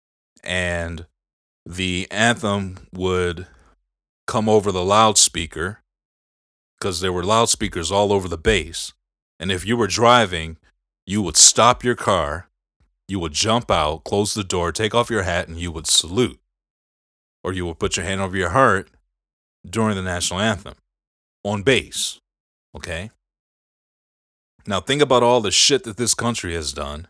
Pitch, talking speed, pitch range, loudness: 95 Hz, 150 wpm, 85-110 Hz, -19 LUFS